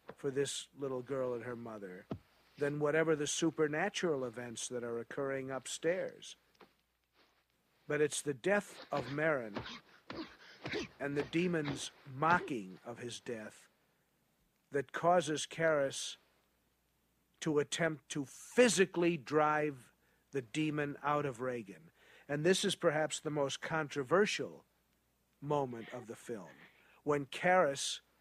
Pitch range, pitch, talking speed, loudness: 135-160 Hz, 145 Hz, 115 wpm, -36 LUFS